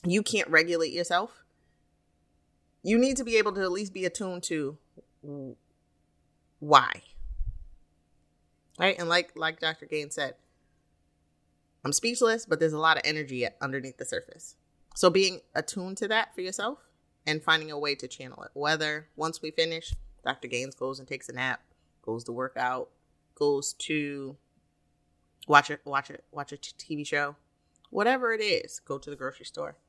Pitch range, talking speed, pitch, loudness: 130-180 Hz, 170 wpm, 150 Hz, -28 LUFS